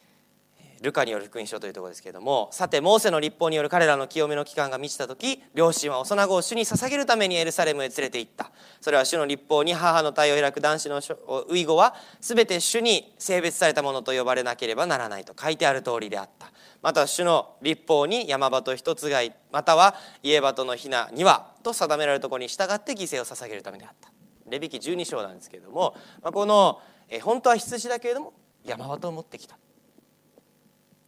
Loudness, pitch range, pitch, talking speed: -24 LUFS, 140-195 Hz, 155 Hz, 400 characters per minute